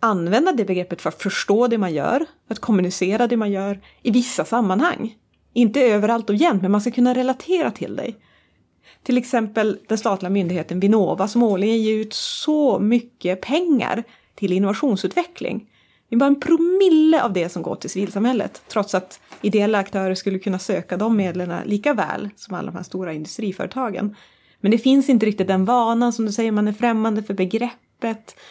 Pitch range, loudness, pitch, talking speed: 195-245 Hz, -20 LUFS, 220 Hz, 180 wpm